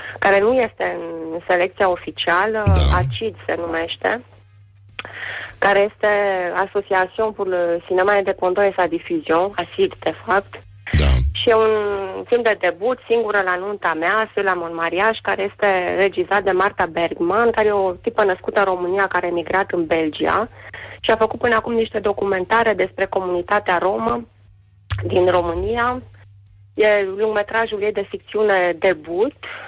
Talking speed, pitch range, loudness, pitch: 140 wpm, 170-210 Hz, -19 LUFS, 190 Hz